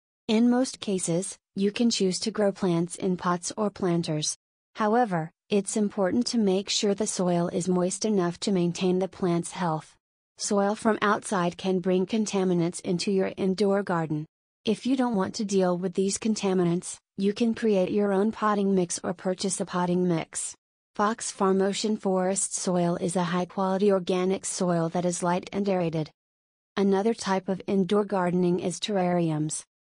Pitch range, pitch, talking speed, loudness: 180-205 Hz, 190 Hz, 165 wpm, -26 LUFS